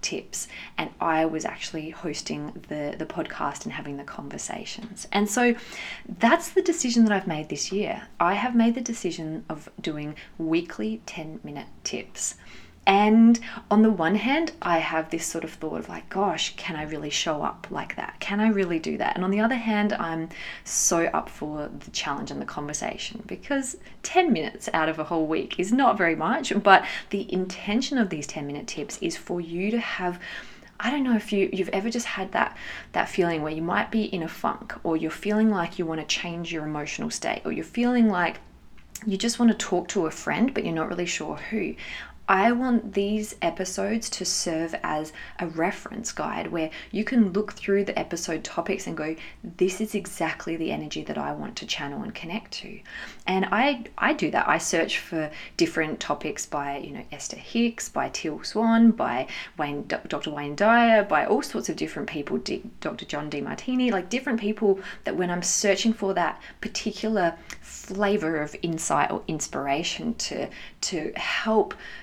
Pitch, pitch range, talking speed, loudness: 195 Hz, 160-225 Hz, 190 wpm, -26 LUFS